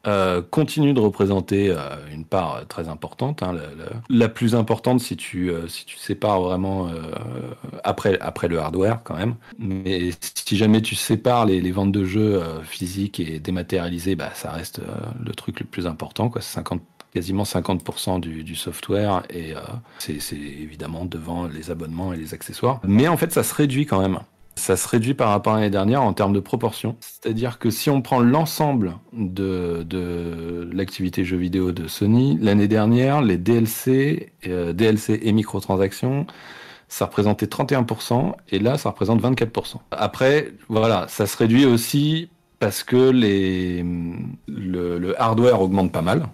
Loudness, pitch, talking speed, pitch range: -22 LUFS, 100 Hz, 175 wpm, 90-115 Hz